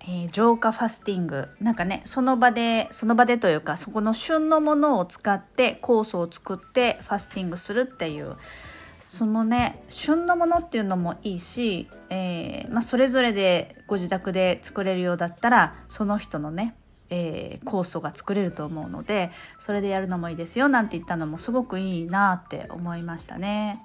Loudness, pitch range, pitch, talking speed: -25 LUFS, 175-235 Hz, 200 Hz, 370 characters per minute